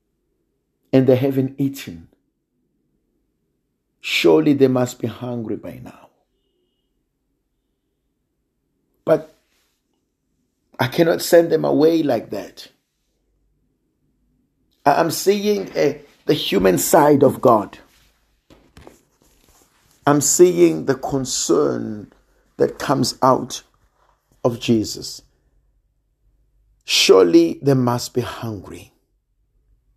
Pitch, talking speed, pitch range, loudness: 135 Hz, 80 wpm, 120-160 Hz, -17 LUFS